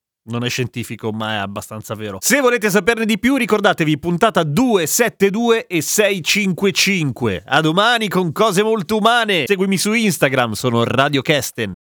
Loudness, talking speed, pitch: -16 LUFS, 145 wpm, 180 Hz